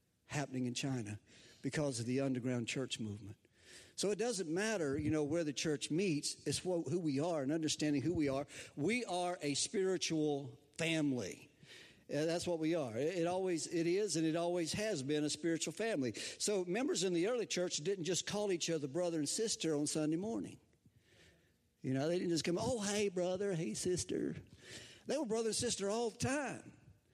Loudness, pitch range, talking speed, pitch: -38 LUFS, 140-180 Hz, 195 wpm, 165 Hz